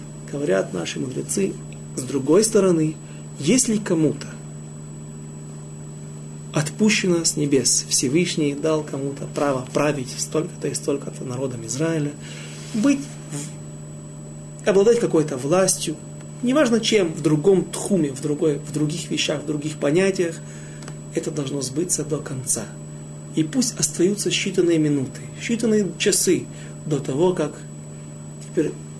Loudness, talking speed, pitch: -21 LUFS, 110 wpm, 145 Hz